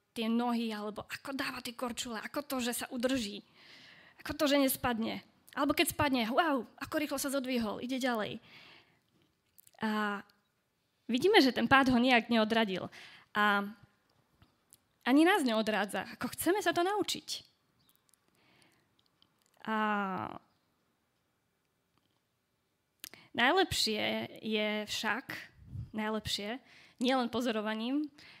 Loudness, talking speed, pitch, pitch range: -32 LUFS, 105 wpm, 245 Hz, 215-275 Hz